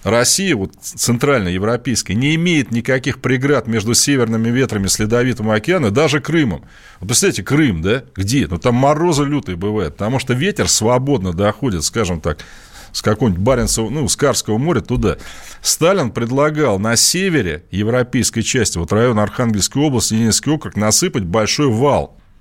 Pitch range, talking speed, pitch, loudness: 105-140 Hz, 150 wpm, 120 Hz, -16 LUFS